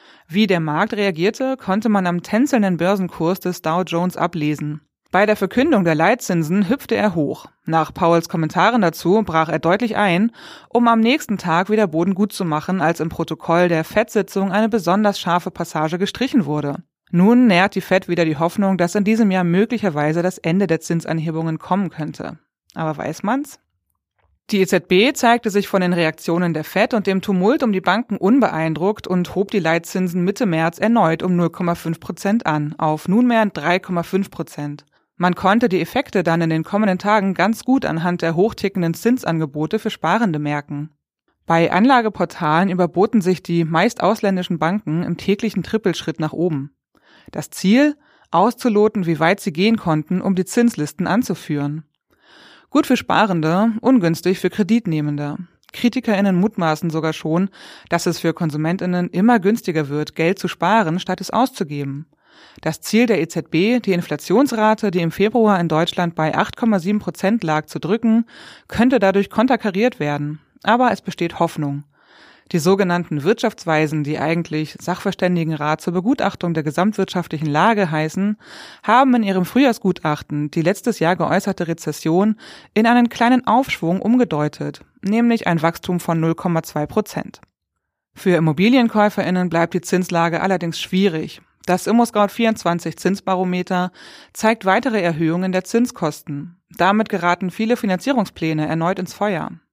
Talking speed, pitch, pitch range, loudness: 145 wpm, 185 Hz, 165-210 Hz, -18 LUFS